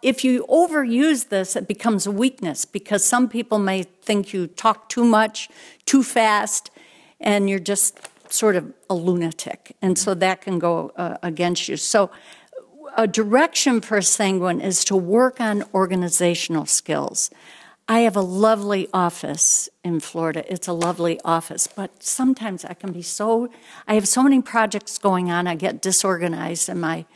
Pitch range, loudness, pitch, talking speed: 180-230 Hz, -20 LUFS, 200 Hz, 165 wpm